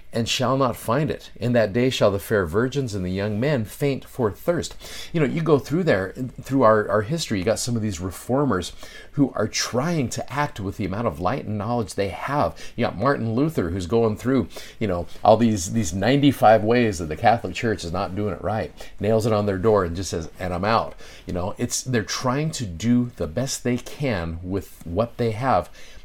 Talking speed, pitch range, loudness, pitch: 225 wpm, 100-125 Hz, -23 LUFS, 115 Hz